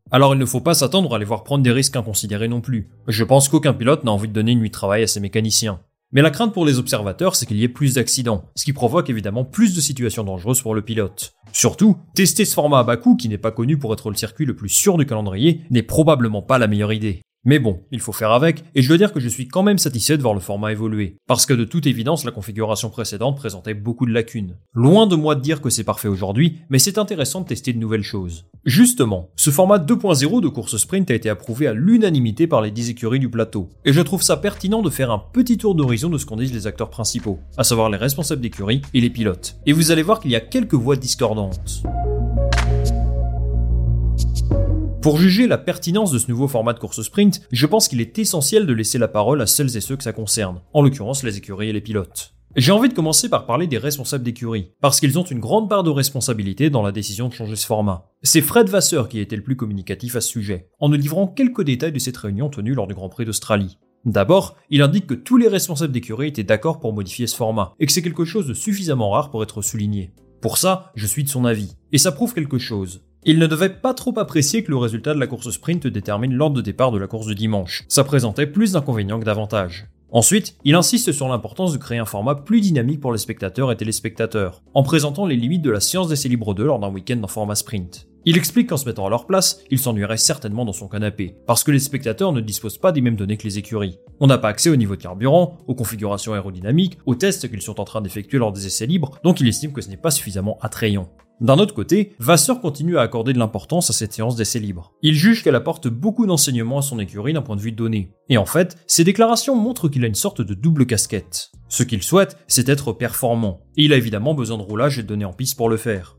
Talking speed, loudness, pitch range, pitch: 250 wpm, -19 LUFS, 110-155 Hz, 120 Hz